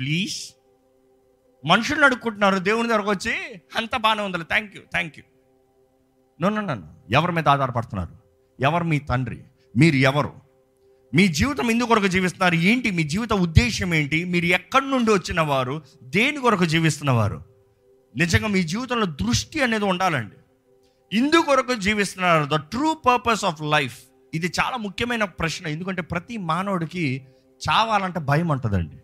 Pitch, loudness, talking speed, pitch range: 165 Hz, -22 LUFS, 130 wpm, 130-210 Hz